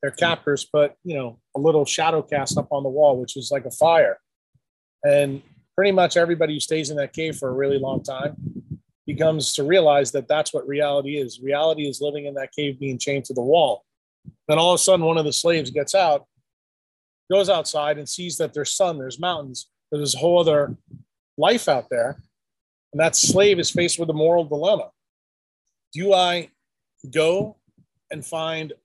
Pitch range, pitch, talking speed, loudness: 140-165 Hz, 150 Hz, 190 wpm, -21 LUFS